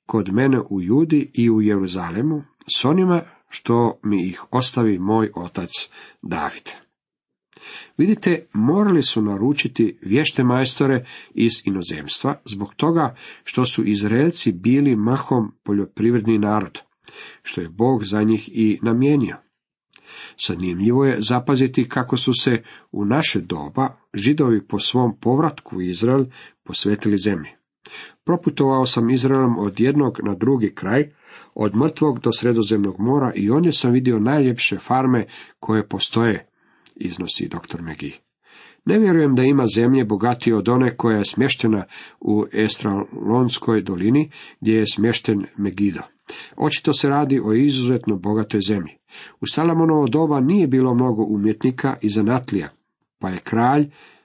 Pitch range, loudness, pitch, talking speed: 105-135 Hz, -19 LUFS, 120 Hz, 130 wpm